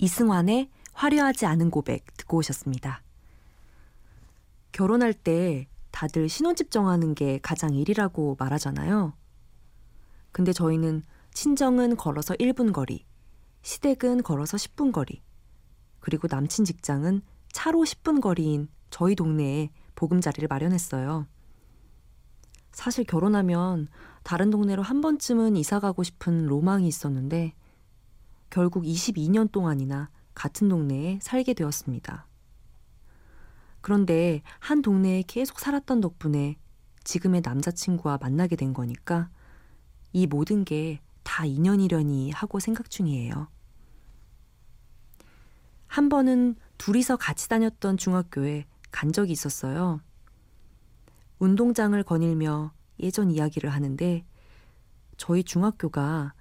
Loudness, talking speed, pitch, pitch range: -26 LUFS, 250 characters per minute, 170 Hz, 145-205 Hz